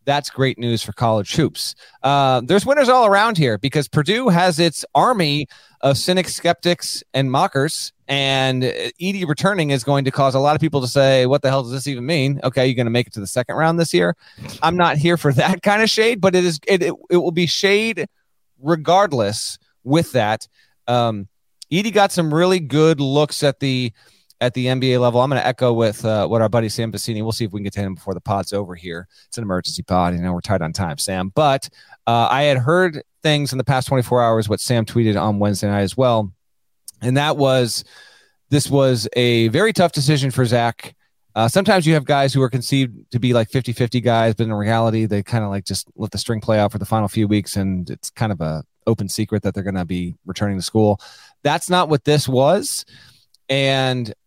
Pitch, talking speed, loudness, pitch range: 130 Hz, 225 wpm, -18 LUFS, 110-150 Hz